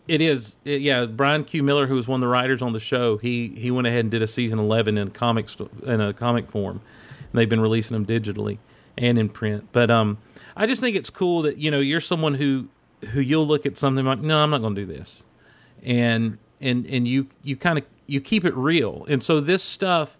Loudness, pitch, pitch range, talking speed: -22 LUFS, 125 Hz, 115-145 Hz, 245 wpm